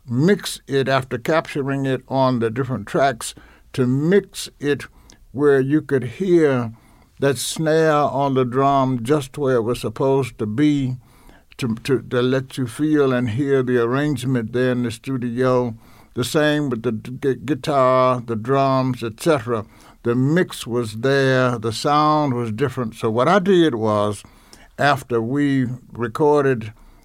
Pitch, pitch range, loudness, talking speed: 130 Hz, 120-145 Hz, -20 LUFS, 150 wpm